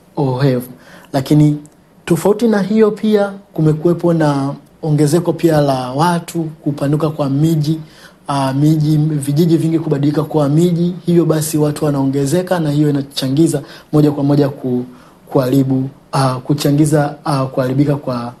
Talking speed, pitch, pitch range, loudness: 125 wpm, 150 Hz, 140-165 Hz, -15 LUFS